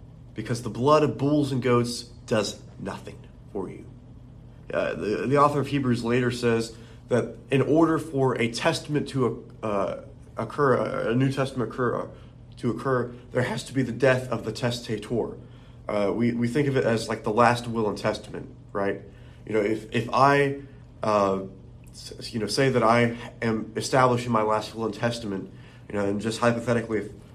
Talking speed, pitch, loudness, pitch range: 180 wpm, 120 Hz, -25 LUFS, 110-130 Hz